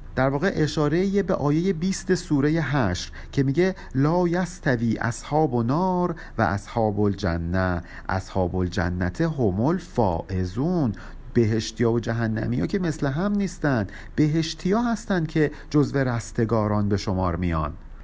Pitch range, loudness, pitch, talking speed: 105-165 Hz, -24 LUFS, 130 Hz, 125 wpm